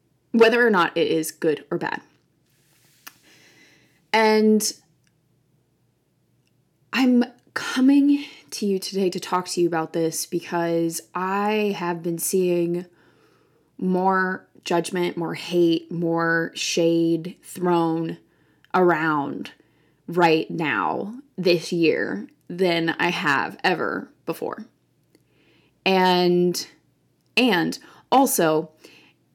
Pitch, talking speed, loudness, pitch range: 175 Hz, 90 wpm, -22 LUFS, 165-195 Hz